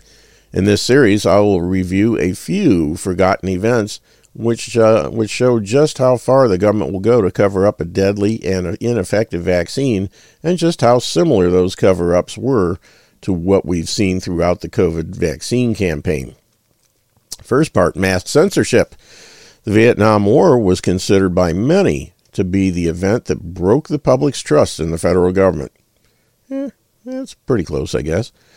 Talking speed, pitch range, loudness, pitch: 160 wpm, 90-115 Hz, -15 LUFS, 100 Hz